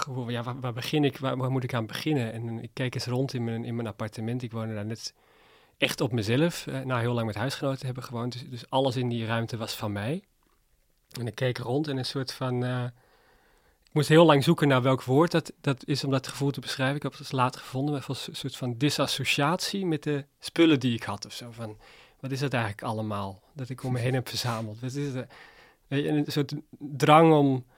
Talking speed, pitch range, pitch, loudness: 240 wpm, 120-145 Hz, 130 Hz, -28 LUFS